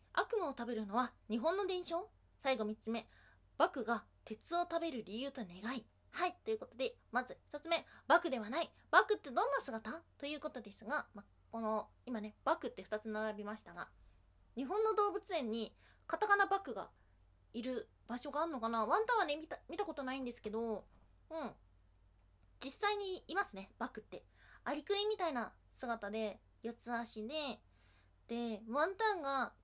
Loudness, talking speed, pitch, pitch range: -39 LUFS, 320 characters per minute, 255 Hz, 220-335 Hz